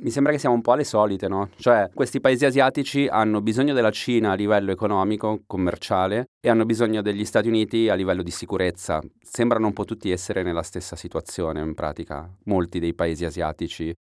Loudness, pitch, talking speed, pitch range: -23 LUFS, 105 Hz, 190 wpm, 85-115 Hz